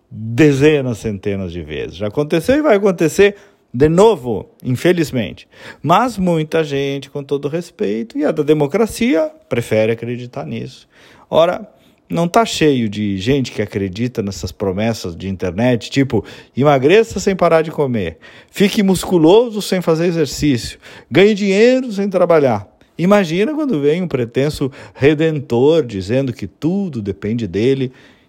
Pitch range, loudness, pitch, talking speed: 115-185 Hz, -16 LUFS, 145 Hz, 135 wpm